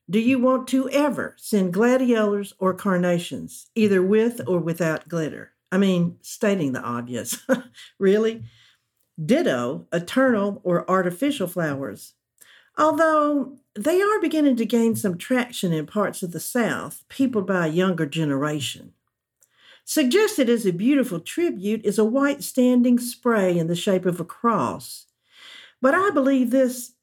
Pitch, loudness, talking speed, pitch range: 215 Hz, -22 LUFS, 140 wpm, 175-260 Hz